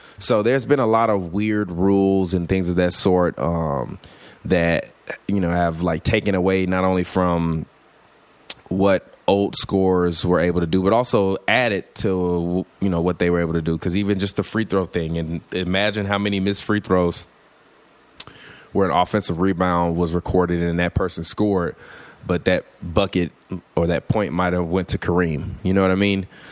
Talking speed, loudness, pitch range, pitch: 190 wpm, -21 LUFS, 85-100 Hz, 90 Hz